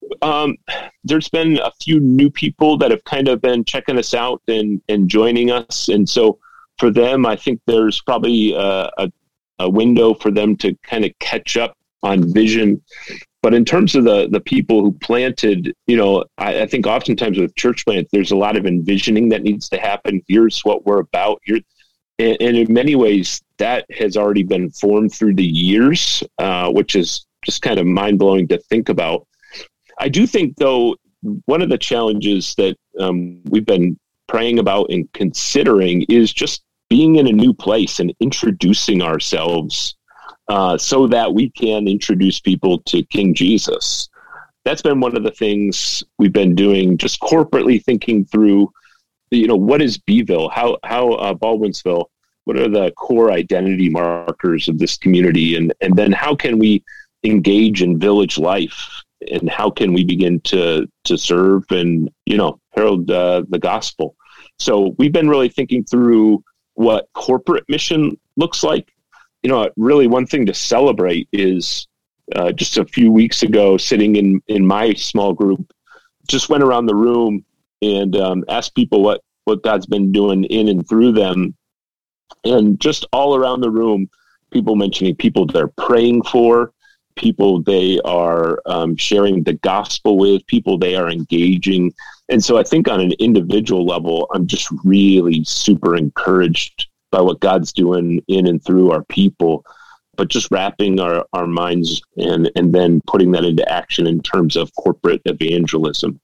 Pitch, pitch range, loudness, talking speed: 100 Hz, 90-115 Hz, -15 LUFS, 170 wpm